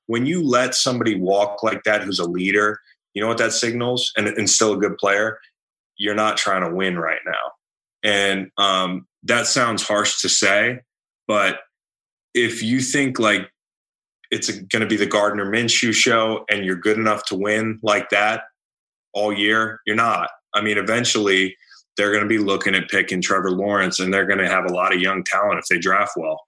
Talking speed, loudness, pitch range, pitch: 195 wpm, -19 LUFS, 95-110 Hz, 105 Hz